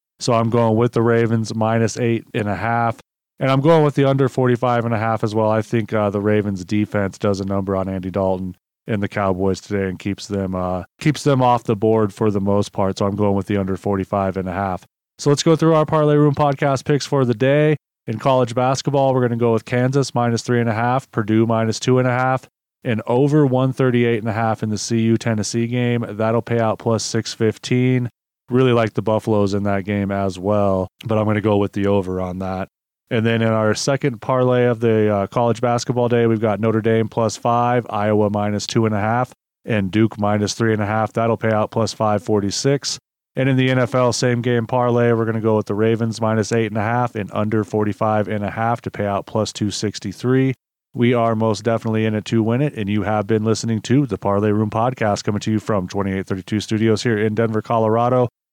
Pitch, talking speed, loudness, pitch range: 110 Hz, 235 wpm, -19 LUFS, 105-120 Hz